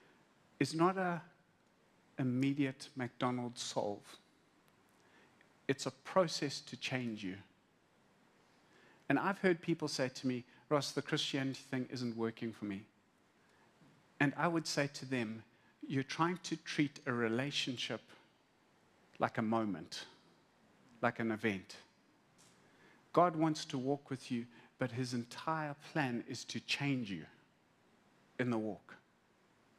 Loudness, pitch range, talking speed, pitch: -38 LUFS, 115-150 Hz, 125 wpm, 130 Hz